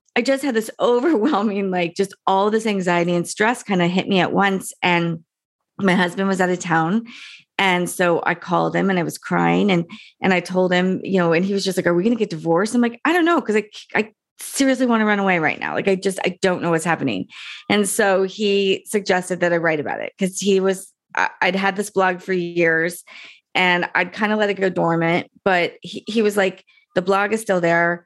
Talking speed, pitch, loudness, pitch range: 235 wpm, 190 Hz, -19 LUFS, 175-210 Hz